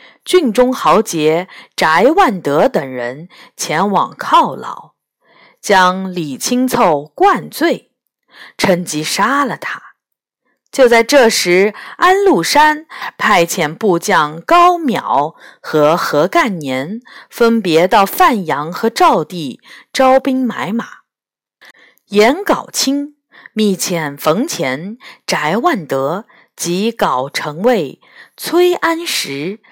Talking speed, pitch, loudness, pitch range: 140 characters per minute, 225 Hz, -13 LUFS, 170-280 Hz